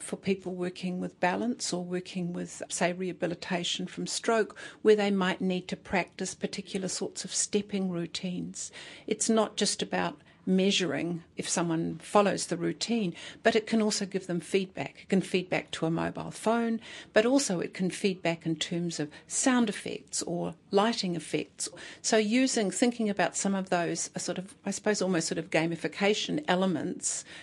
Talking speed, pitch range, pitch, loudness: 170 wpm, 175-205 Hz, 185 Hz, -30 LUFS